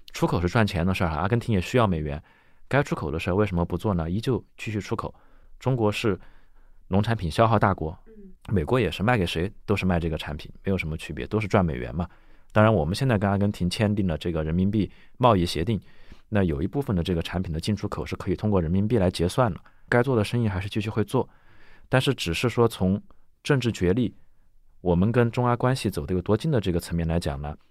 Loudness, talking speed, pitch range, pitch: -25 LUFS, 345 characters per minute, 85-115 Hz, 100 Hz